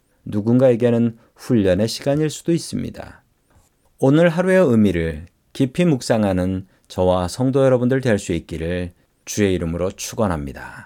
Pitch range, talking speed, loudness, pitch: 90-135 Hz, 310 characters per minute, -19 LUFS, 110 Hz